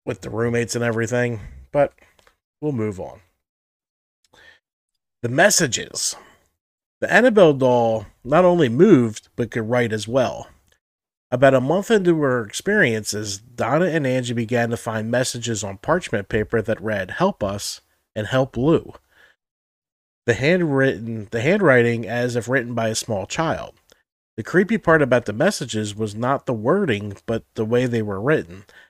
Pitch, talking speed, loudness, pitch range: 120 Hz, 150 wpm, -20 LUFS, 110-135 Hz